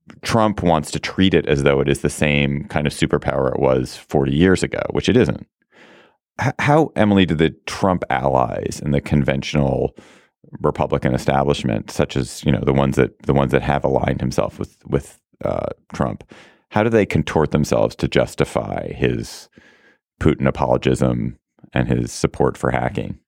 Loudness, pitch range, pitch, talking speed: -19 LUFS, 65-80 Hz, 70 Hz, 170 wpm